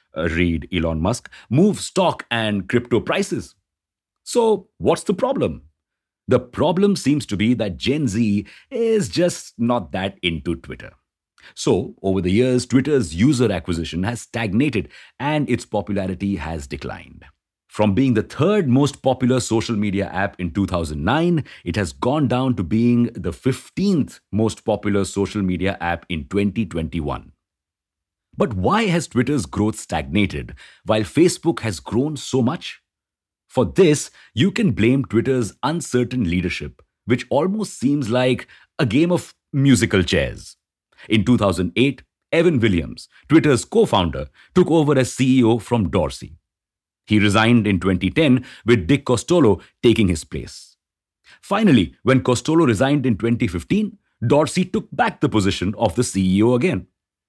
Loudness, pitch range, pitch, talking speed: -20 LUFS, 95-135 Hz, 115 Hz, 140 wpm